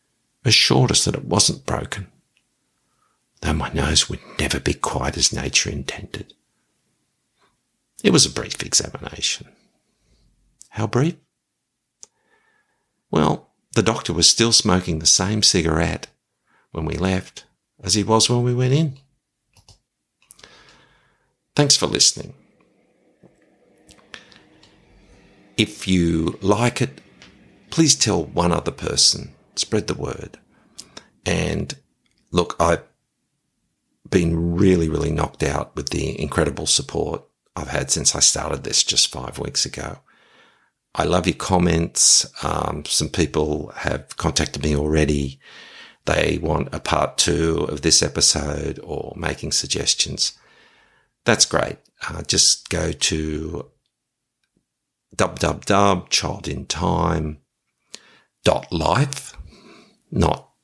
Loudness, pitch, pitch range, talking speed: -19 LUFS, 90 Hz, 80-120 Hz, 115 wpm